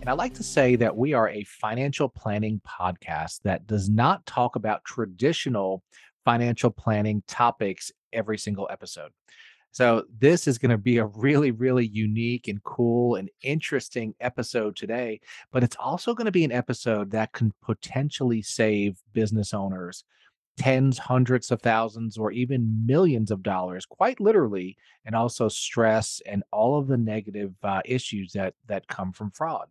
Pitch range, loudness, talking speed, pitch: 105-125 Hz, -25 LUFS, 160 wpm, 115 Hz